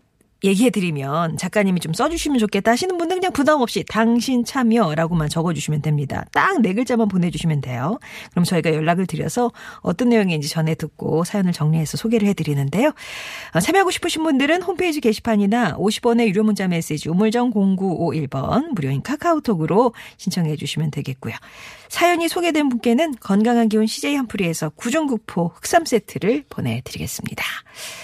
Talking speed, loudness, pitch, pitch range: 390 characters per minute, -20 LUFS, 210 Hz, 160-245 Hz